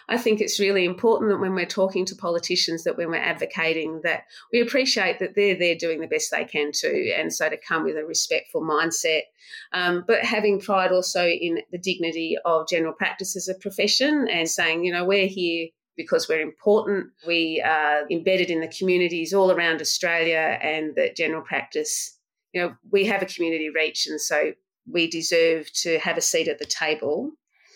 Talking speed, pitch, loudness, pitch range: 190 wpm, 185 Hz, -23 LUFS, 165-215 Hz